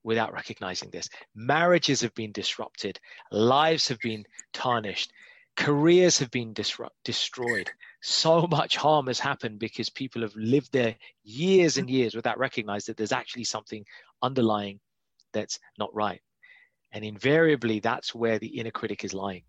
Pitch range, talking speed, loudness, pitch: 110-150 Hz, 150 wpm, -26 LUFS, 120 Hz